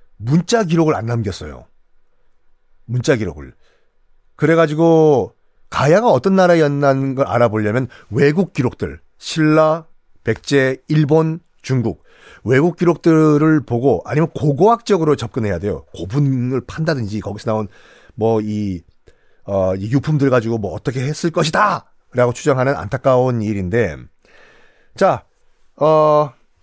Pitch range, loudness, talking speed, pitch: 110-155 Hz, -16 LUFS, 265 characters per minute, 135 Hz